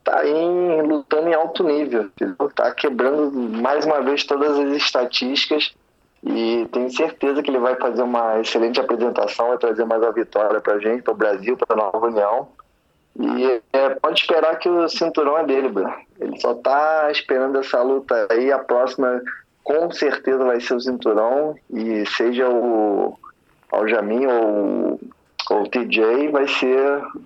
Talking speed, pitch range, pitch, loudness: 160 wpm, 120-150 Hz, 130 Hz, -19 LUFS